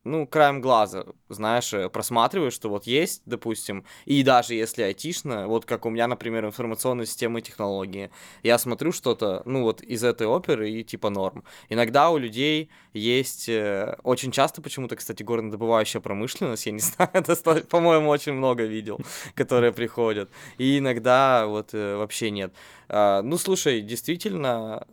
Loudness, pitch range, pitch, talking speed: -24 LUFS, 110-140 Hz, 120 Hz, 145 wpm